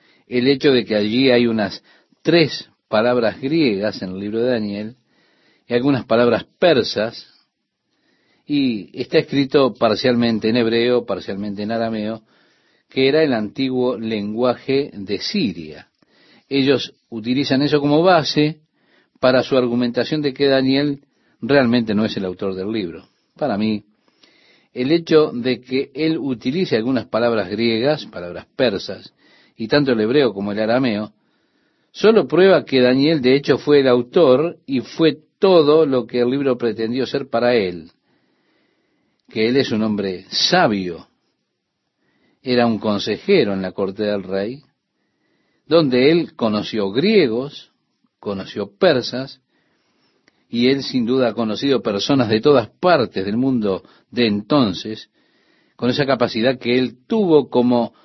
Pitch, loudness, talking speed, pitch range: 125 Hz, -18 LUFS, 140 wpm, 110-140 Hz